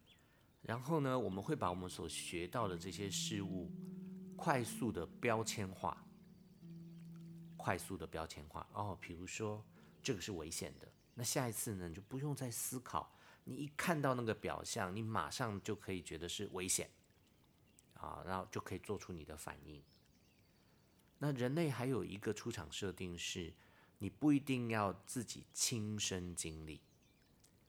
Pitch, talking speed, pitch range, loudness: 105 Hz, 225 characters per minute, 90-130 Hz, -42 LUFS